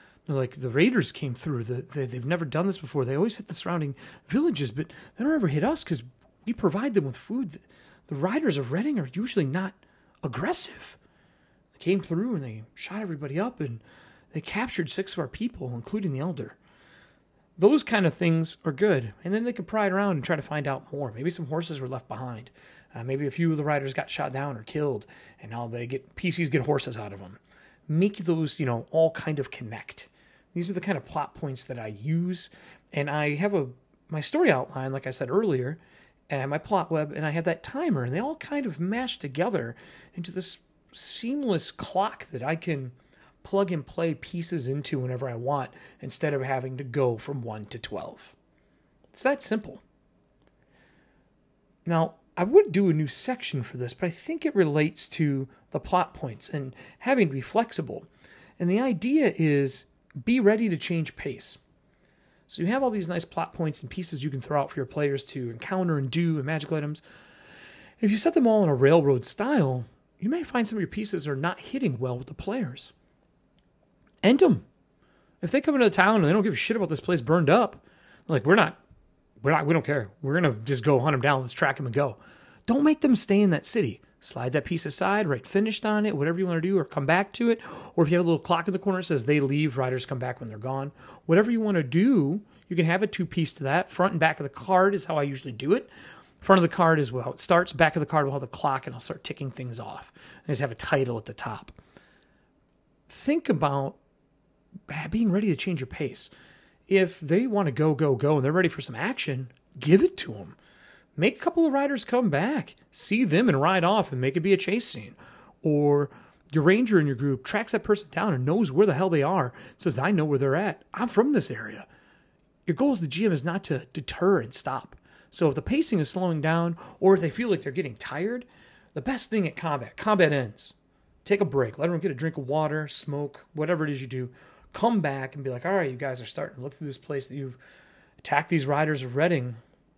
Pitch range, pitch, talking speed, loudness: 140-195 Hz, 160 Hz, 230 wpm, -26 LUFS